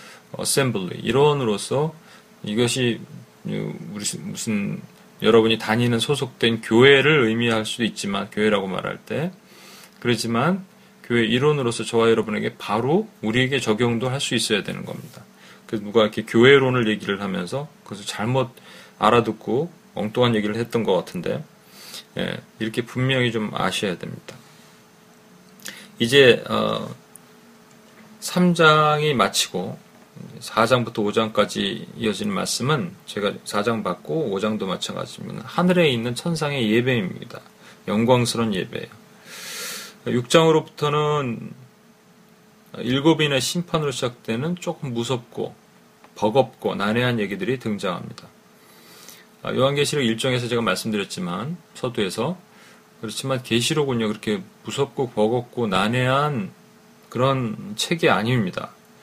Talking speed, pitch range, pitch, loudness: 280 characters per minute, 115-170 Hz, 130 Hz, -22 LUFS